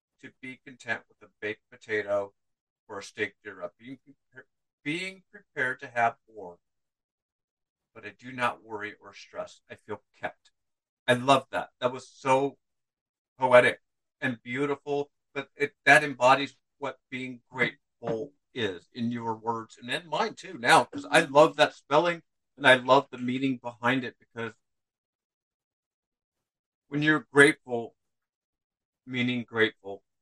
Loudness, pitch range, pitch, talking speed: -26 LUFS, 115-140 Hz, 125 Hz, 140 wpm